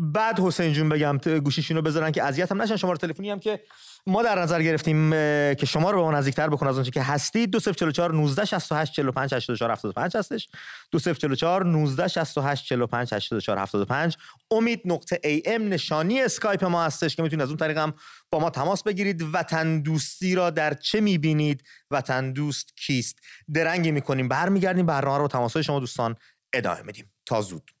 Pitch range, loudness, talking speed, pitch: 140-175 Hz, -25 LUFS, 155 wpm, 155 Hz